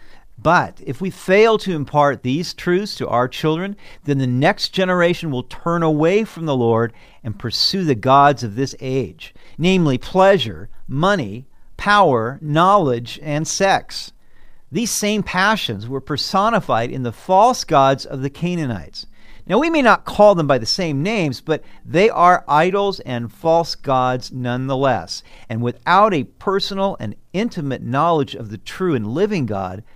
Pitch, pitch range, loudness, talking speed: 145 Hz, 125-185 Hz, -18 LUFS, 155 wpm